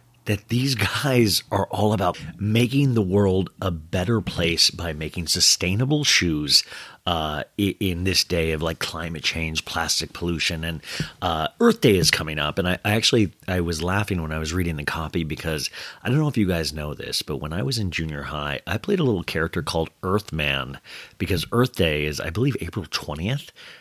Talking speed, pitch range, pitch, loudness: 195 wpm, 80-105 Hz, 90 Hz, -23 LUFS